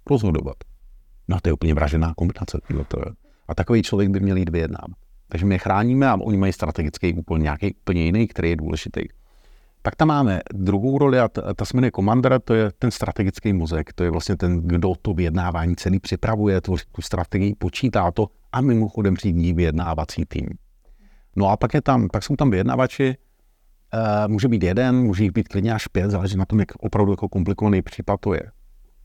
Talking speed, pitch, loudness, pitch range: 190 wpm, 100 Hz, -21 LUFS, 90-110 Hz